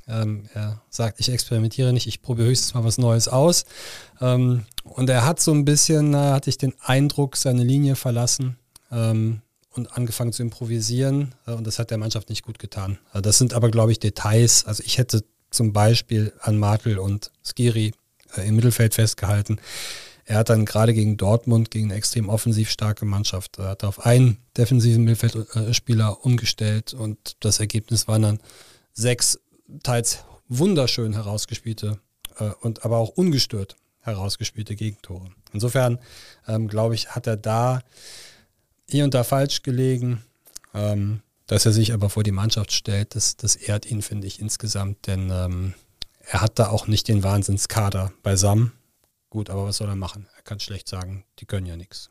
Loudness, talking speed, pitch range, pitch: -22 LUFS, 165 wpm, 105-120 Hz, 110 Hz